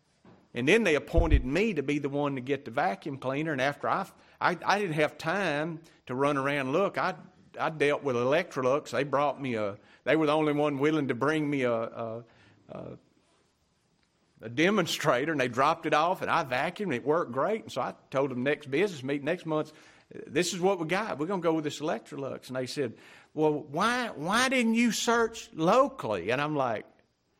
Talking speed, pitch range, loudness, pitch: 210 wpm, 135-175 Hz, -29 LUFS, 150 Hz